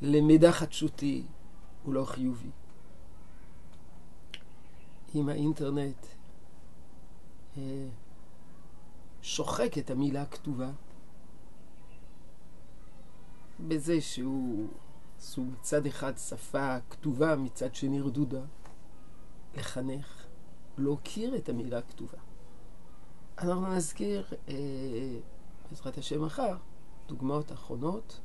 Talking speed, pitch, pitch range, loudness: 75 wpm, 135 Hz, 95-145 Hz, -33 LUFS